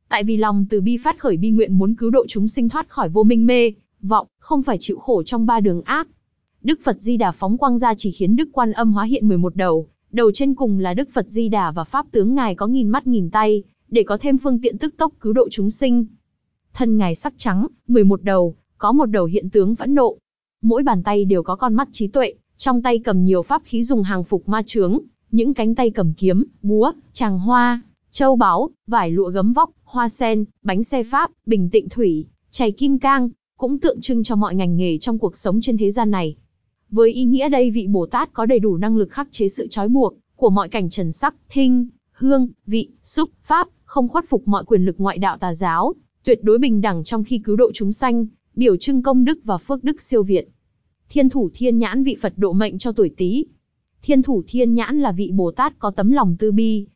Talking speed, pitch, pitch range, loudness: 235 wpm, 225 Hz, 200-255 Hz, -18 LUFS